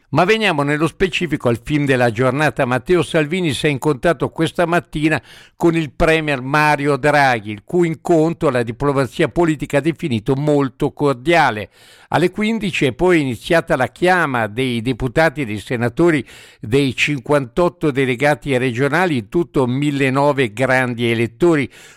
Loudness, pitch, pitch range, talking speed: -17 LUFS, 145 Hz, 130-165 Hz, 140 wpm